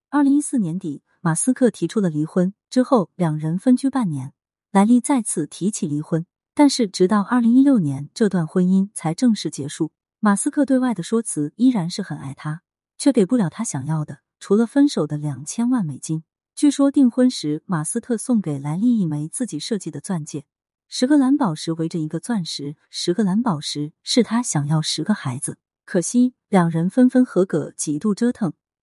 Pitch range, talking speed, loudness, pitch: 155-245 Hz, 285 characters per minute, -20 LUFS, 190 Hz